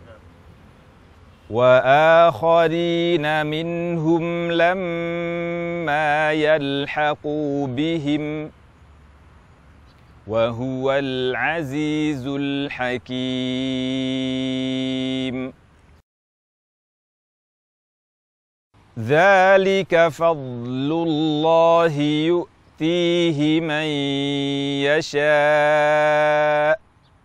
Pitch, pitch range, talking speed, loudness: 150 Hz, 130-165 Hz, 30 wpm, -20 LUFS